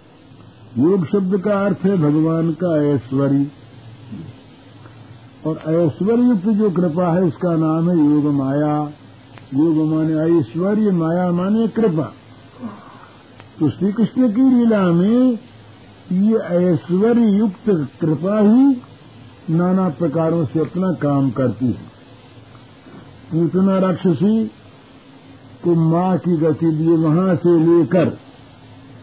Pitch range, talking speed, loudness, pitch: 135-185 Hz, 110 wpm, -17 LUFS, 165 Hz